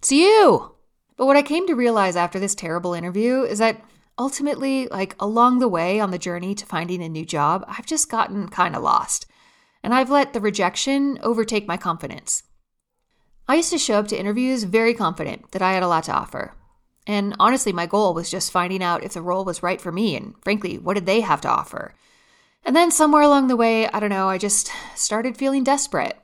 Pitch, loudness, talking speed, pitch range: 210 Hz, -20 LUFS, 215 wpm, 185-260 Hz